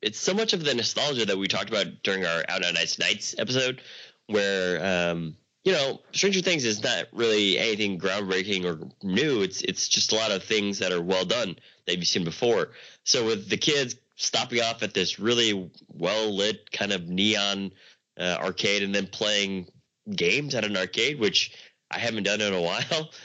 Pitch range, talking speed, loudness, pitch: 95-125 Hz, 195 wpm, -25 LUFS, 100 Hz